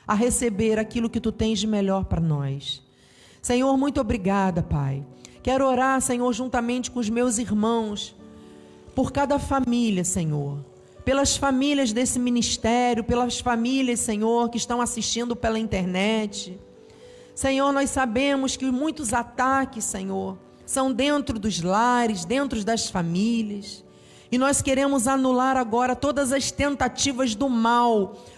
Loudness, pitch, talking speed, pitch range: -23 LUFS, 240 Hz, 130 wpm, 215-265 Hz